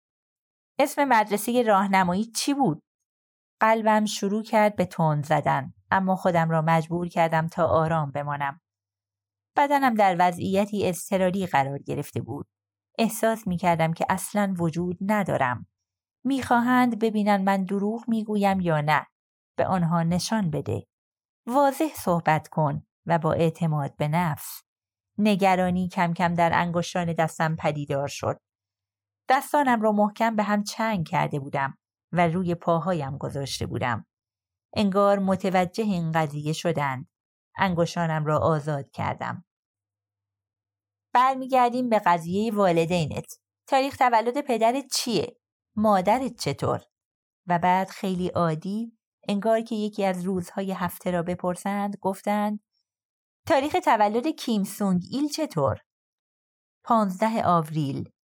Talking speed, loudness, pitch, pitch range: 115 wpm, -25 LUFS, 180 Hz, 155-210 Hz